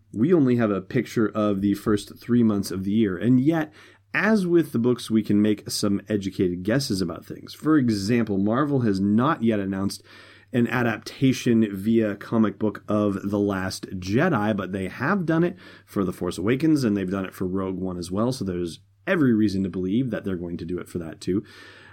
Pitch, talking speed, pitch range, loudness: 105 Hz, 210 wpm, 95-120 Hz, -24 LUFS